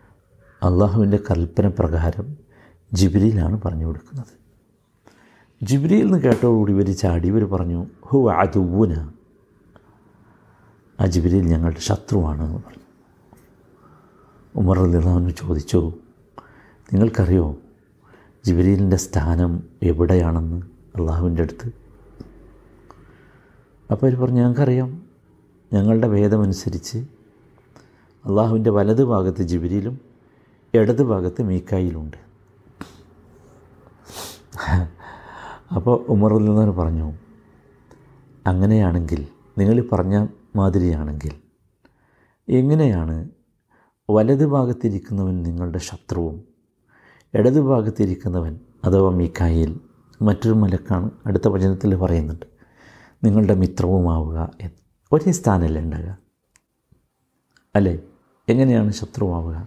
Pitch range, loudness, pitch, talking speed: 90-115 Hz, -20 LUFS, 100 Hz, 70 wpm